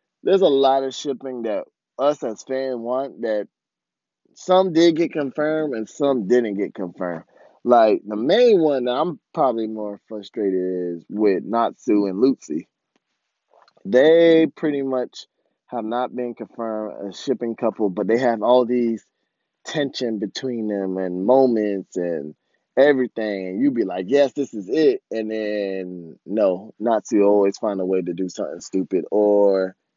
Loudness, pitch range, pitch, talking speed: -21 LUFS, 100-135 Hz, 115 Hz, 155 wpm